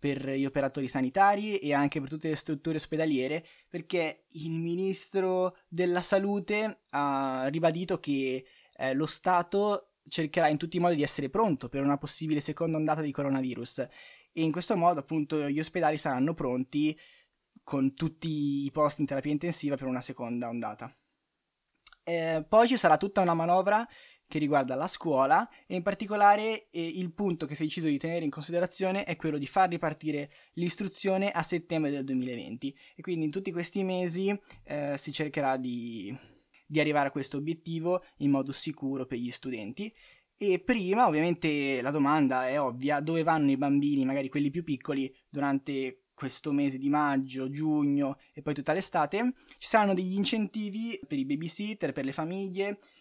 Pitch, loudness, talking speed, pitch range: 155 Hz, -30 LUFS, 170 wpm, 140-180 Hz